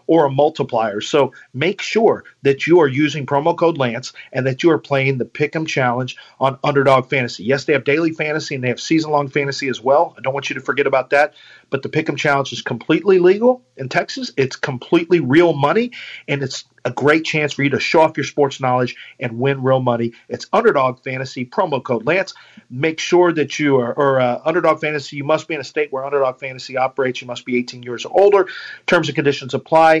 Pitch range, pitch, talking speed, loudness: 130-160 Hz, 140 Hz, 220 wpm, -17 LUFS